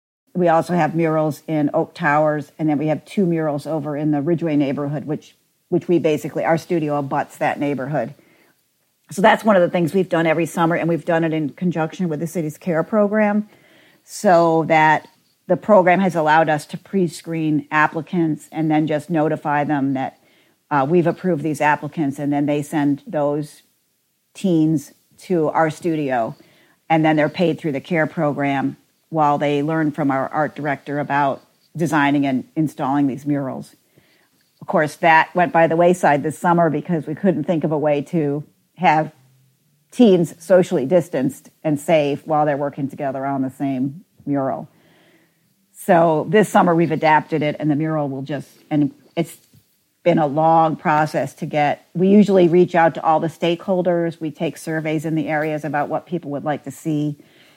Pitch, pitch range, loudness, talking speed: 155 Hz, 145-170 Hz, -19 LUFS, 175 wpm